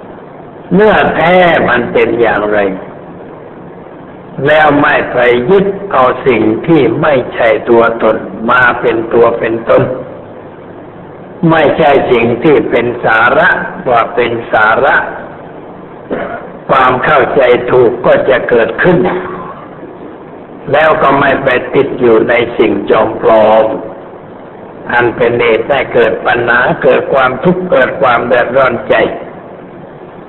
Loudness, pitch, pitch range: -9 LUFS, 115 Hz, 105-150 Hz